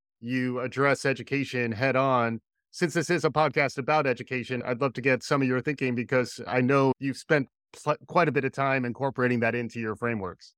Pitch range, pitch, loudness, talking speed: 125-140 Hz, 130 Hz, -27 LUFS, 205 wpm